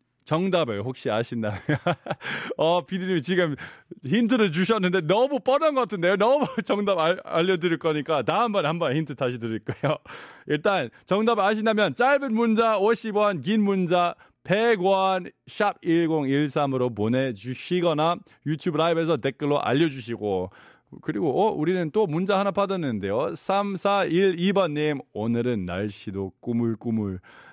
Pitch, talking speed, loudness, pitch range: 170 Hz, 280 characters per minute, -24 LUFS, 135-200 Hz